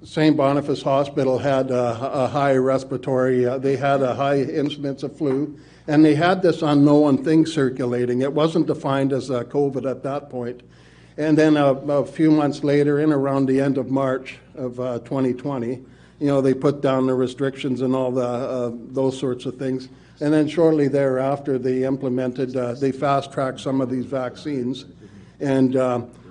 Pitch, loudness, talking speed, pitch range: 135 Hz, -21 LUFS, 180 wpm, 130-145 Hz